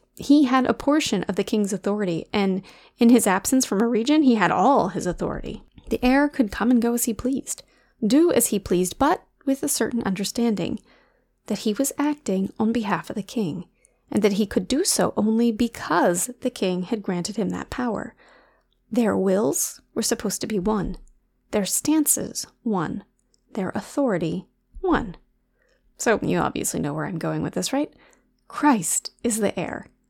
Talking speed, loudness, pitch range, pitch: 175 wpm, -23 LUFS, 200-260 Hz, 225 Hz